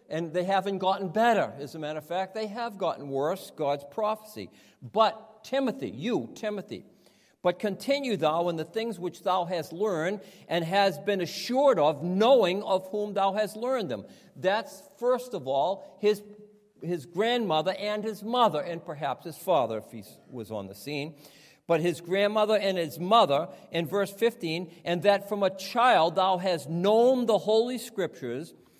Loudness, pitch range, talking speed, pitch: -28 LUFS, 170-215 Hz, 170 wpm, 195 Hz